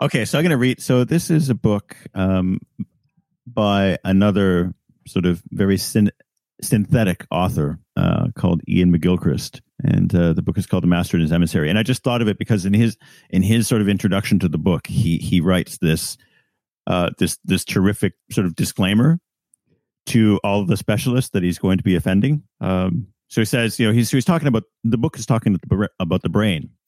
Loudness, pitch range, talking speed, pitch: -19 LUFS, 95-125 Hz, 205 wpm, 105 Hz